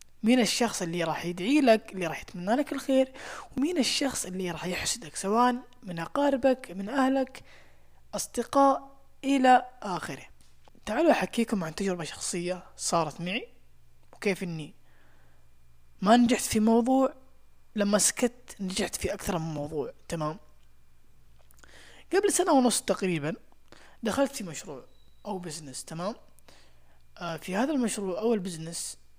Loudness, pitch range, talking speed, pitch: -28 LUFS, 165-255 Hz, 125 wpm, 200 Hz